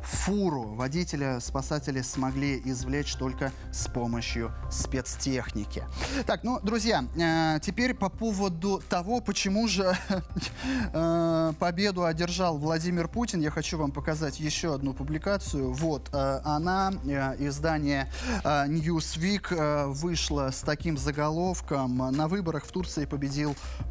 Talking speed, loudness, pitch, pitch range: 105 wpm, -29 LUFS, 155 Hz, 140-185 Hz